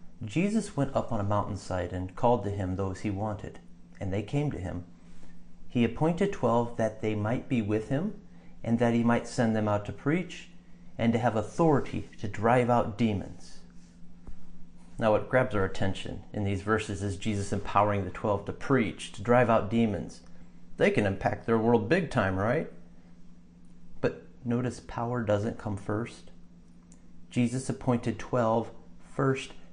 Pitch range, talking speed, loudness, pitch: 90-120 Hz, 165 wpm, -29 LUFS, 105 Hz